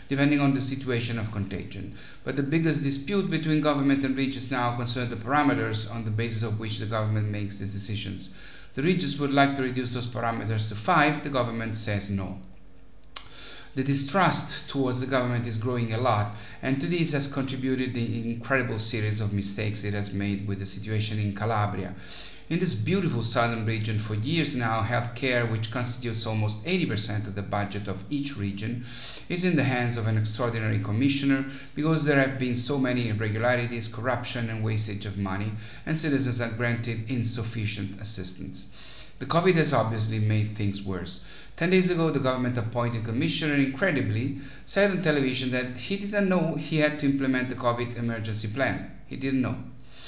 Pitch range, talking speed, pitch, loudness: 105-135 Hz, 180 wpm, 120 Hz, -27 LUFS